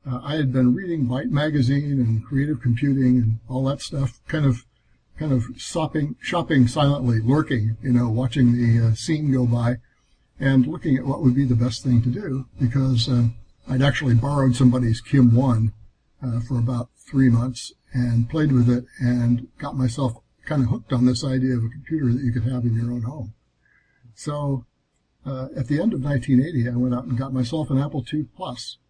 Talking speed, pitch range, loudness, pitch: 195 wpm, 120-135 Hz, -22 LUFS, 125 Hz